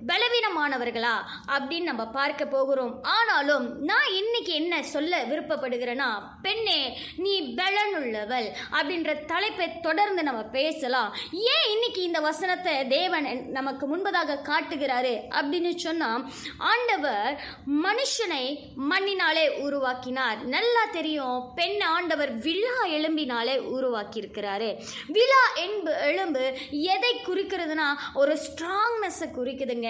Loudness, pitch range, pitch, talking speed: -26 LUFS, 265-370 Hz, 310 Hz, 100 wpm